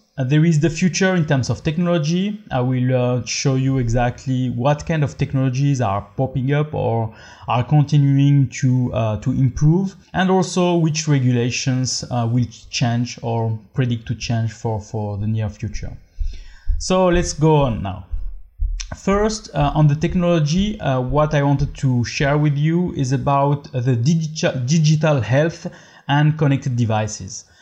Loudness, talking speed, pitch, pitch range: -19 LUFS, 155 wpm, 135 Hz, 120-155 Hz